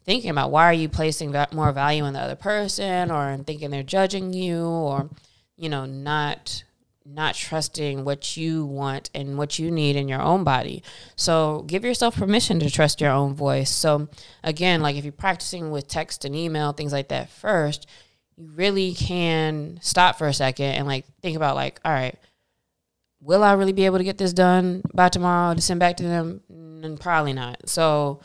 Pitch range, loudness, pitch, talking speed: 140-175 Hz, -22 LUFS, 155 Hz, 195 wpm